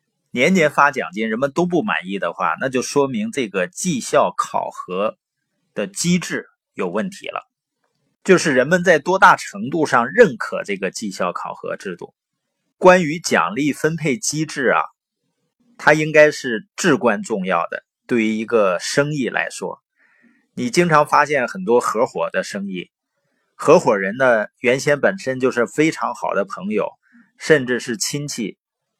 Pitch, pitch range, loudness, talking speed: 150 Hz, 125-185 Hz, -18 LUFS, 225 characters per minute